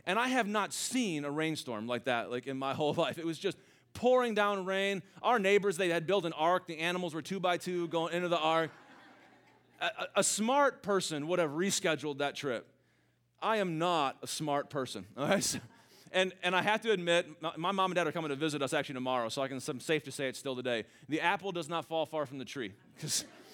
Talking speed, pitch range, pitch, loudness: 235 wpm, 145-195 Hz, 170 Hz, -33 LUFS